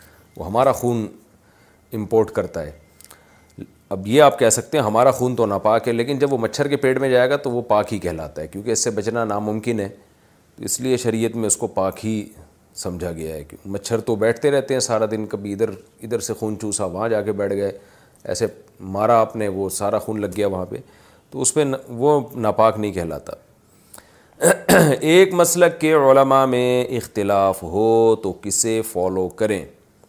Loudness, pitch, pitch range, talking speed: -19 LUFS, 110 Hz, 100-125 Hz, 195 wpm